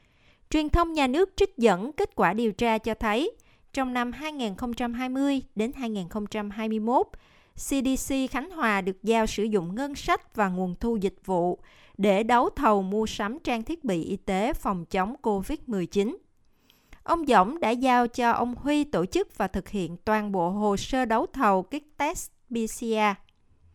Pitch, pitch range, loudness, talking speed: 230 Hz, 205-270 Hz, -27 LUFS, 165 wpm